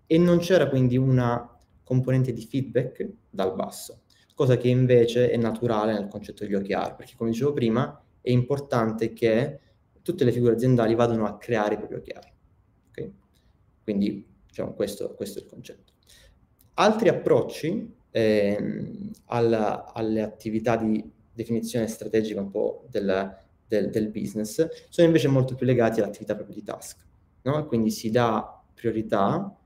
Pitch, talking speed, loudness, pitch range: 115 Hz, 150 wpm, -25 LUFS, 105-125 Hz